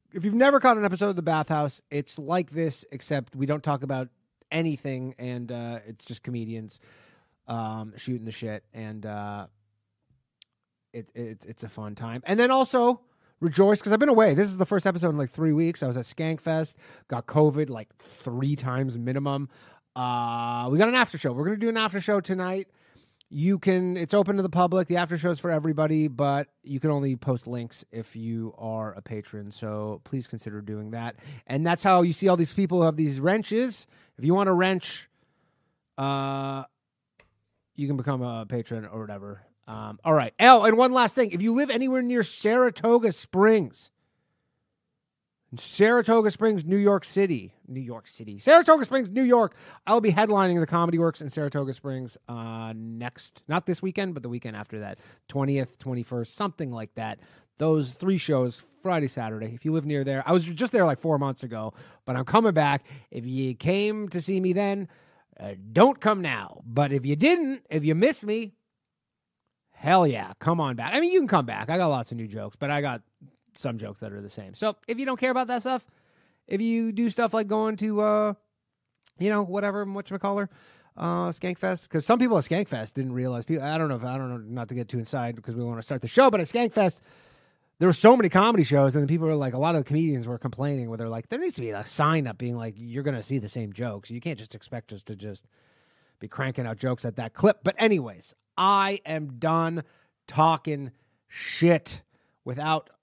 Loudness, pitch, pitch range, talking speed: -25 LUFS, 145 Hz, 120-195 Hz, 210 wpm